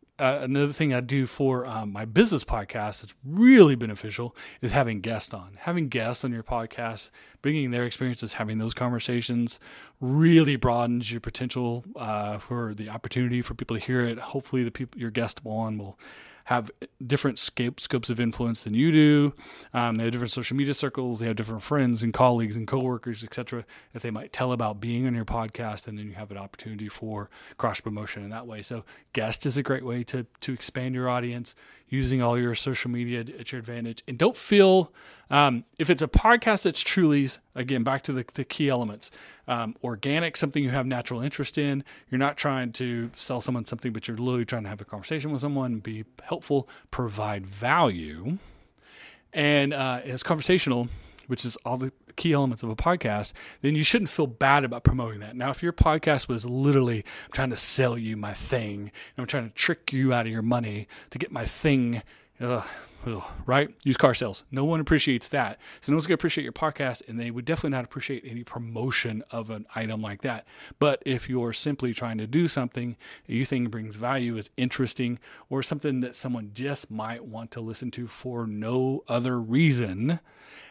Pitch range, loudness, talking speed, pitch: 115-135 Hz, -27 LUFS, 200 wpm, 125 Hz